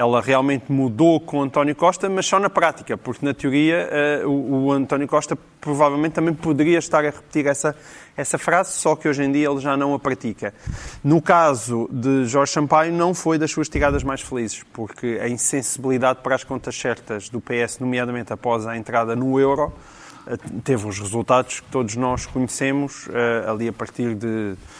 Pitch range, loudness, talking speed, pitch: 120-150 Hz, -21 LUFS, 180 wpm, 135 Hz